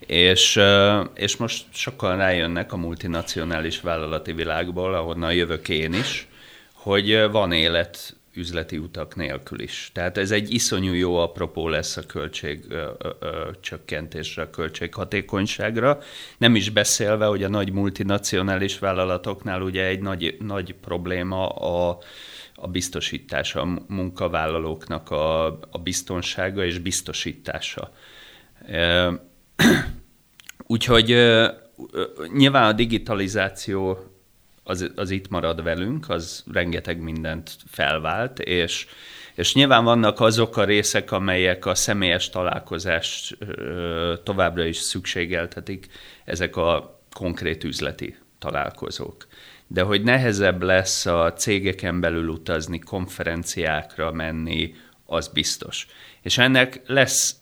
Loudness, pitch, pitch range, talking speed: -22 LUFS, 95 Hz, 85-105 Hz, 105 wpm